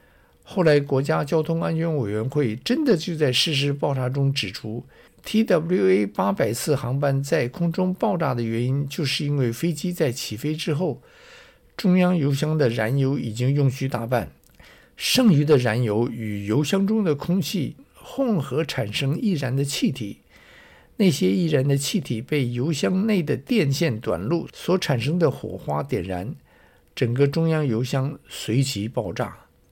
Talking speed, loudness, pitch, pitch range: 235 characters per minute, -23 LUFS, 145 Hz, 125-170 Hz